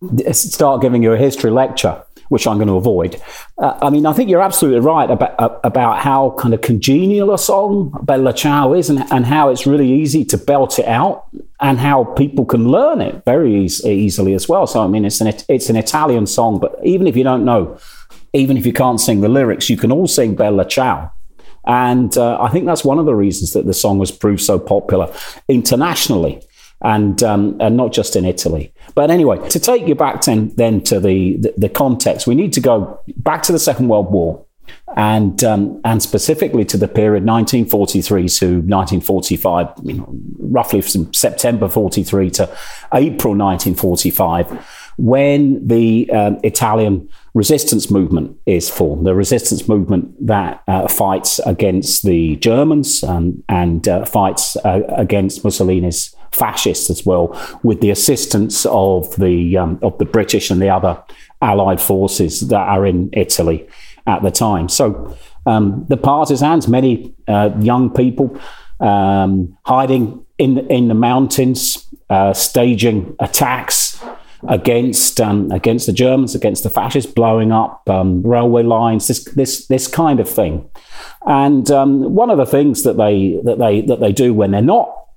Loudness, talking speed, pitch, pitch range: -14 LUFS, 180 wpm, 115 Hz, 100-135 Hz